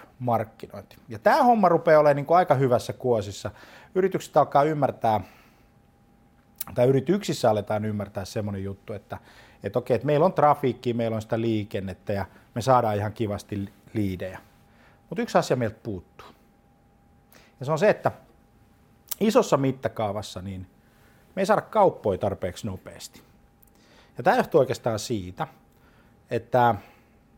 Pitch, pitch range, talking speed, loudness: 115 Hz, 100-140 Hz, 135 wpm, -24 LUFS